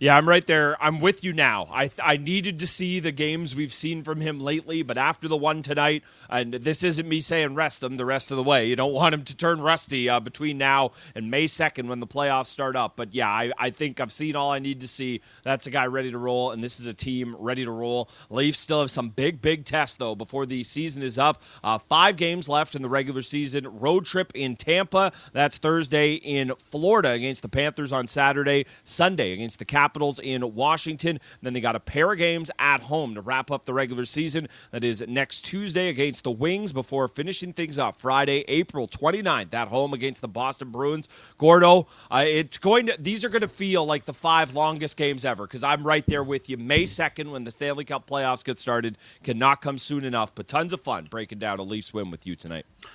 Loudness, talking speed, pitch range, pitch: -24 LUFS, 230 wpm, 125-155 Hz, 140 Hz